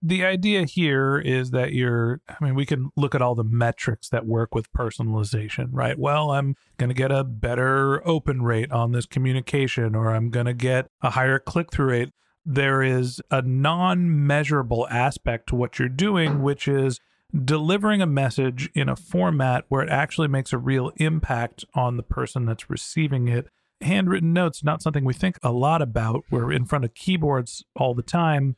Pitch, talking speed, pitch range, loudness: 135 Hz, 190 wpm, 125-150 Hz, -23 LUFS